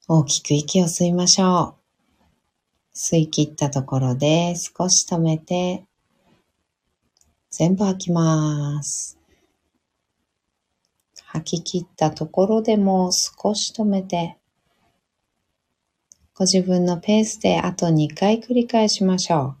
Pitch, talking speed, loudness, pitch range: 175 Hz, 200 characters per minute, -20 LUFS, 155-190 Hz